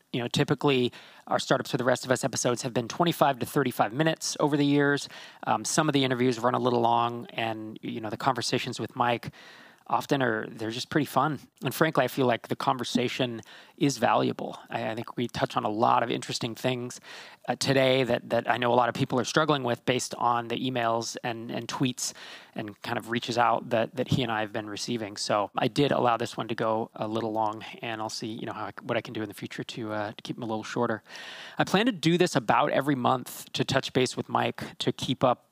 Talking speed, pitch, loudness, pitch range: 245 wpm, 125 Hz, -28 LUFS, 115-135 Hz